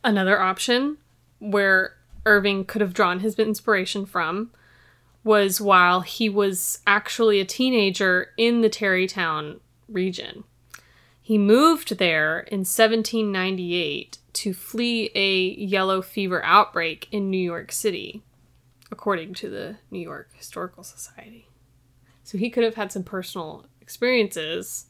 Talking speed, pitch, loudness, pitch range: 125 wpm, 195 Hz, -22 LUFS, 180-215 Hz